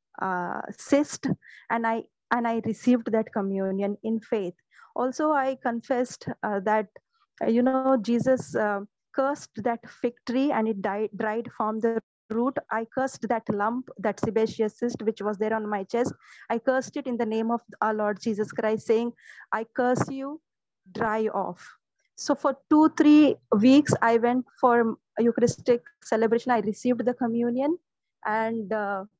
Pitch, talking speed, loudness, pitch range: 230 Hz, 160 wpm, -26 LUFS, 220-250 Hz